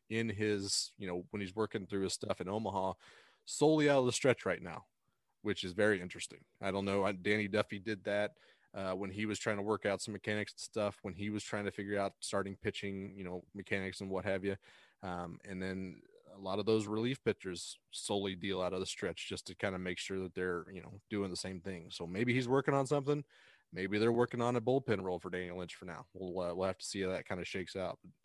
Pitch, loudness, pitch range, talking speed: 100 Hz, -37 LUFS, 95-105 Hz, 245 wpm